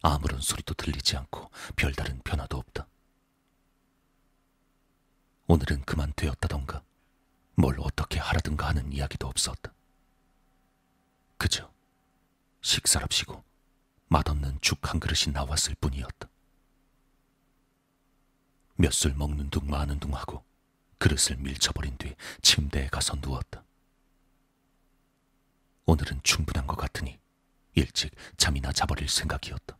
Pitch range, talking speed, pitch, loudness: 70-90 Hz, 235 characters per minute, 80 Hz, -28 LUFS